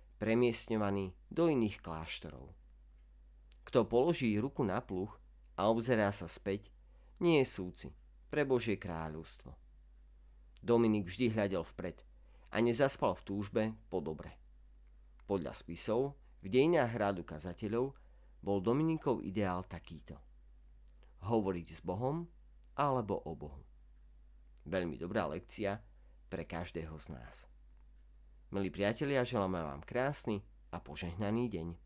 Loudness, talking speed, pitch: -36 LUFS, 115 wpm, 90 Hz